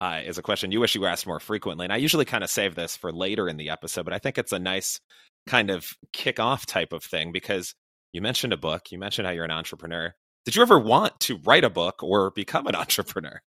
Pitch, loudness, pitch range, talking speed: 90 Hz, -25 LUFS, 85-100 Hz, 260 wpm